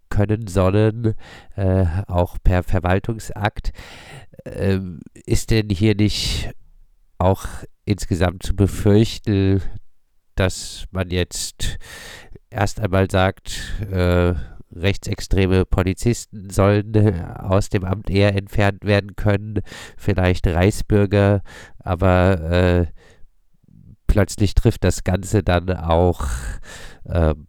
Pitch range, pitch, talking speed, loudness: 90-105 Hz, 95 Hz, 95 wpm, -20 LUFS